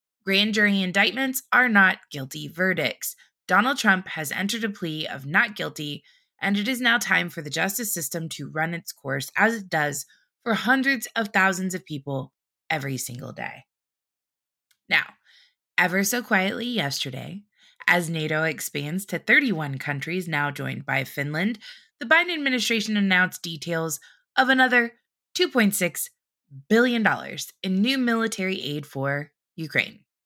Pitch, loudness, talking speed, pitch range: 185 Hz, -23 LUFS, 140 wpm, 155-230 Hz